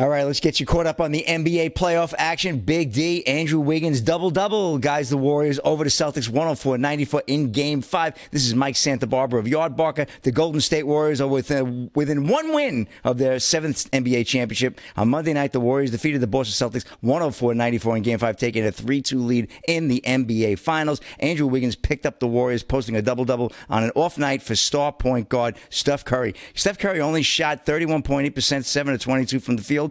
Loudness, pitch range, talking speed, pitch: -22 LUFS, 125-155 Hz, 200 wpm, 140 Hz